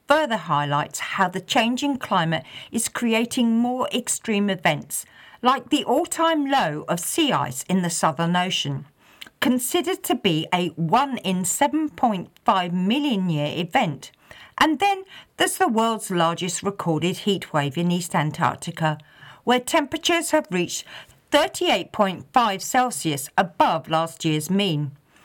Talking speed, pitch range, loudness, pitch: 130 wpm, 165-260 Hz, -22 LUFS, 190 Hz